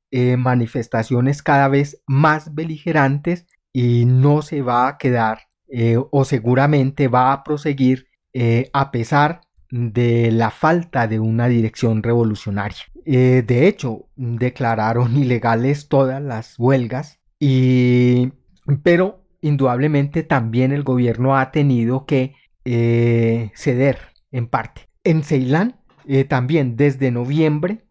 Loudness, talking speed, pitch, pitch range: -18 LUFS, 120 wpm, 130 Hz, 120-145 Hz